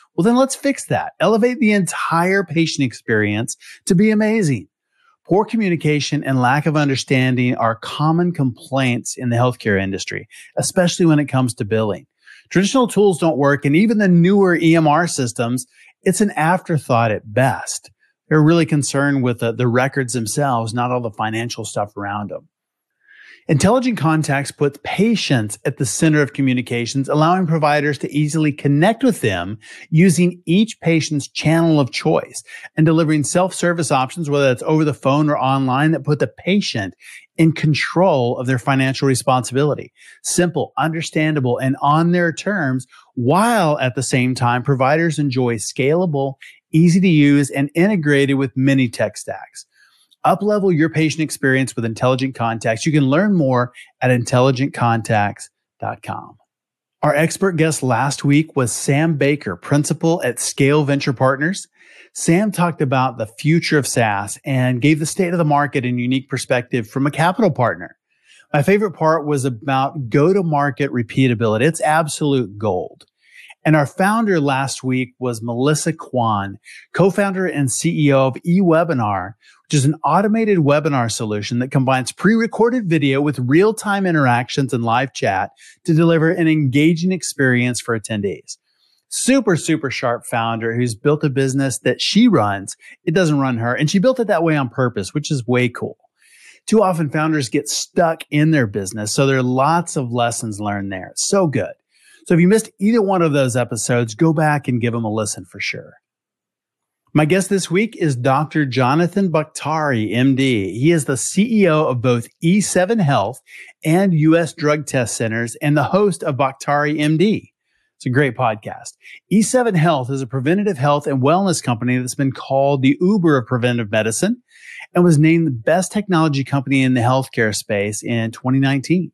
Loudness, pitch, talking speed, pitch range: -17 LUFS, 145 Hz, 160 wpm, 125-170 Hz